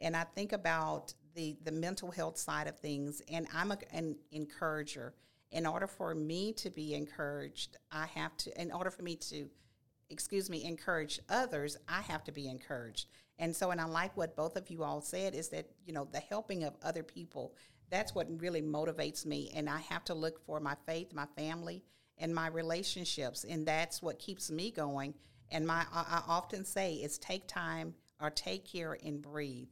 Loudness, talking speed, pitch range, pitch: -40 LUFS, 200 wpm, 145-170 Hz, 160 Hz